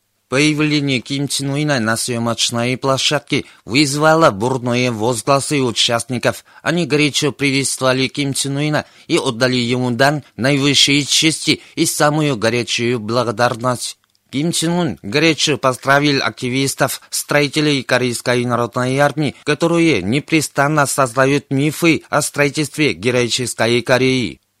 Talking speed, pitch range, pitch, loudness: 105 wpm, 125-145 Hz, 135 Hz, -16 LUFS